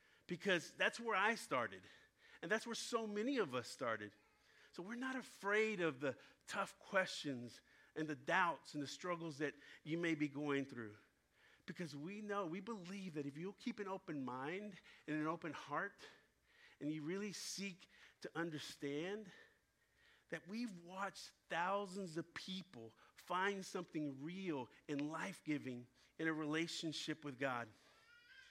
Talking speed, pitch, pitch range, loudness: 150 wpm, 170 Hz, 150-200 Hz, -44 LUFS